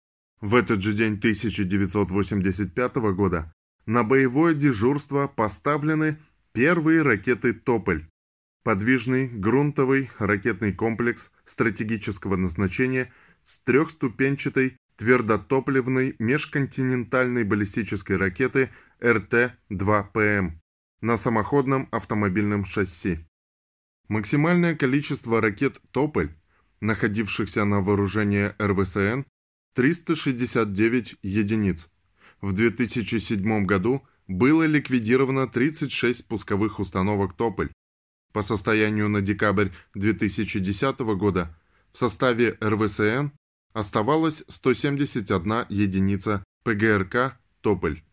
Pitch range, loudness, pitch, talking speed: 100-130 Hz, -24 LUFS, 110 Hz, 80 wpm